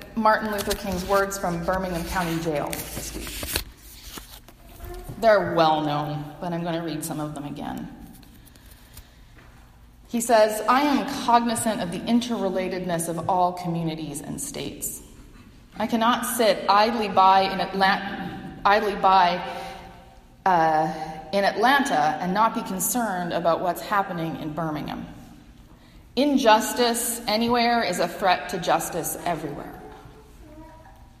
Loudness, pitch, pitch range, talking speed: -23 LUFS, 190 Hz, 165-220 Hz, 125 wpm